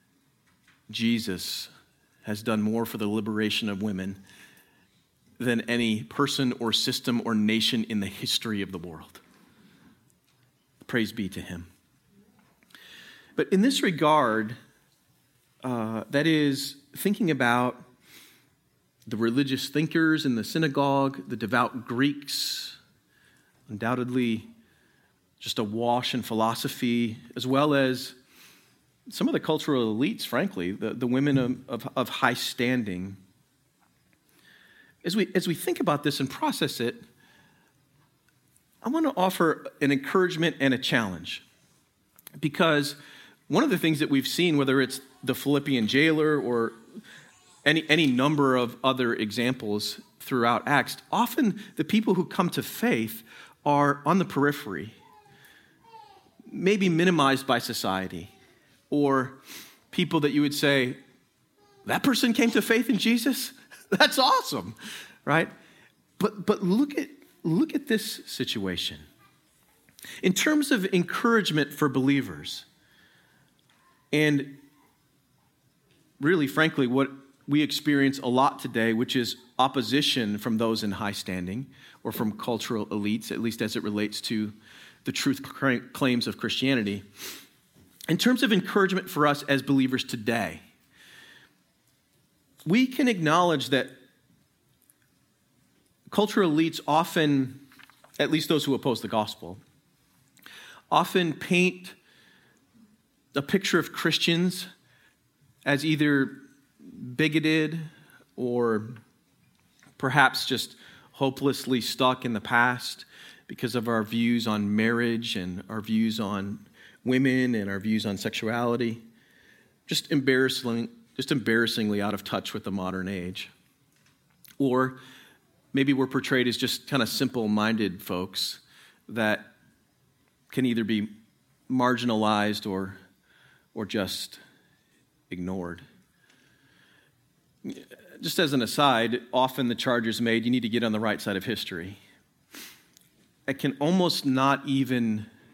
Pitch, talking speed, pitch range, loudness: 130 Hz, 120 wpm, 110-150 Hz, -26 LUFS